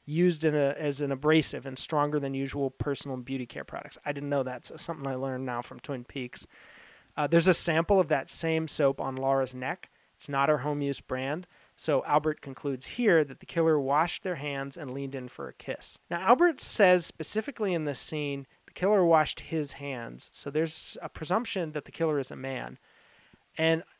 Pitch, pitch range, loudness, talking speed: 145 Hz, 135-160 Hz, -29 LUFS, 205 wpm